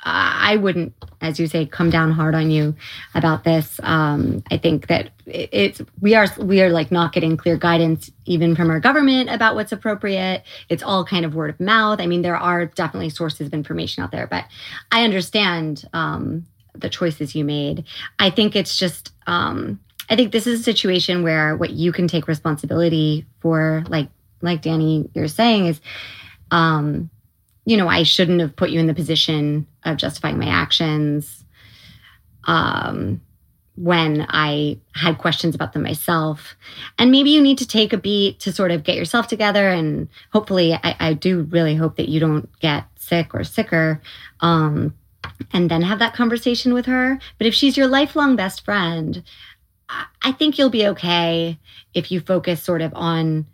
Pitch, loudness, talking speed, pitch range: 165 Hz, -19 LUFS, 180 wpm, 155-195 Hz